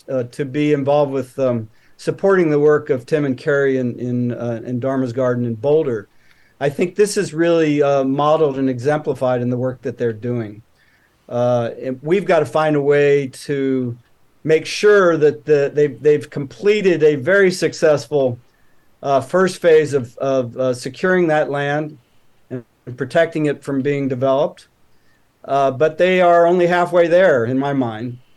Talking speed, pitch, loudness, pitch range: 170 wpm, 140 Hz, -17 LUFS, 130-155 Hz